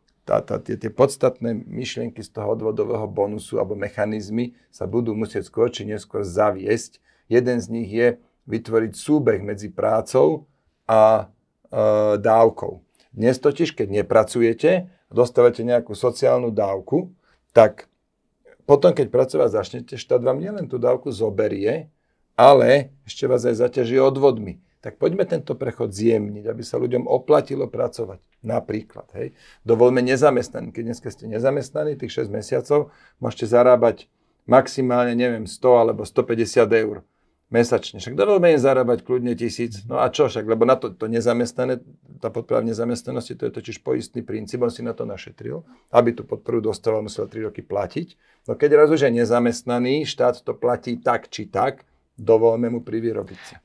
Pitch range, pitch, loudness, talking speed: 110-130 Hz, 120 Hz, -20 LUFS, 150 wpm